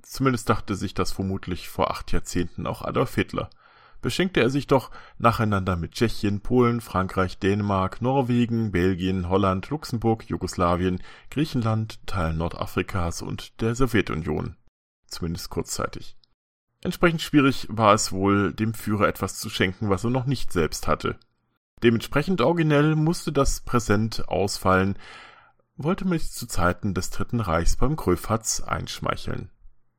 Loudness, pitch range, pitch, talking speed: -25 LUFS, 95-125 Hz, 110 Hz, 135 wpm